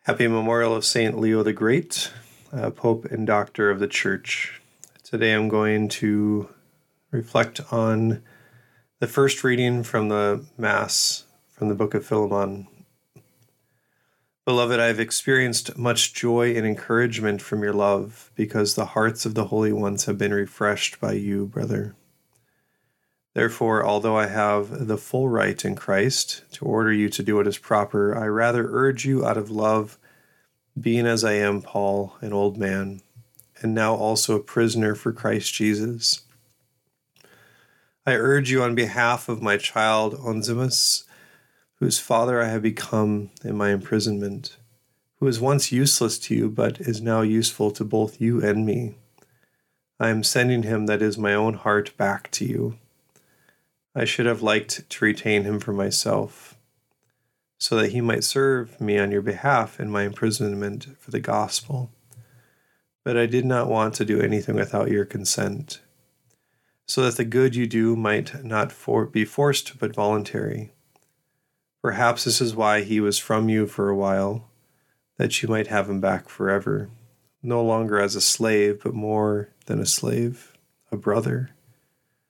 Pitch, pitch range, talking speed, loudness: 110 Hz, 105-125 Hz, 160 wpm, -23 LUFS